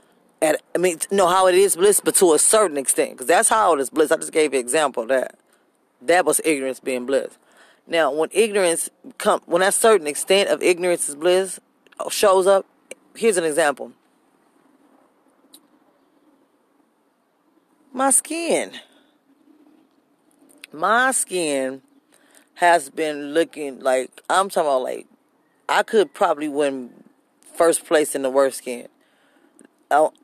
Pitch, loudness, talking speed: 210 Hz, -19 LUFS, 145 wpm